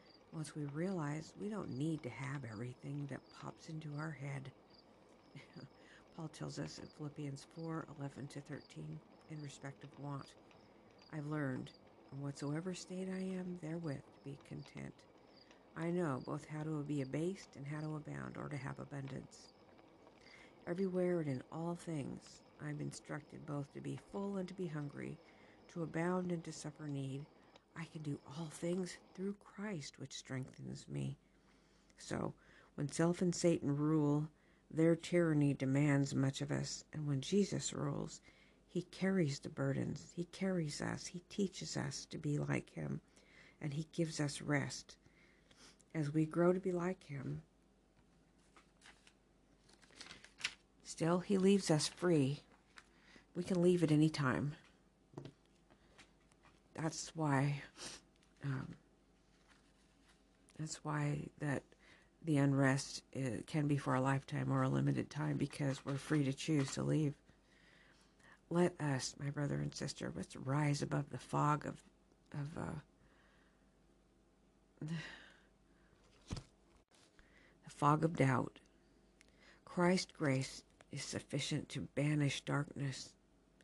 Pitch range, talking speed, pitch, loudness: 140-165 Hz, 135 wpm, 150 Hz, -40 LUFS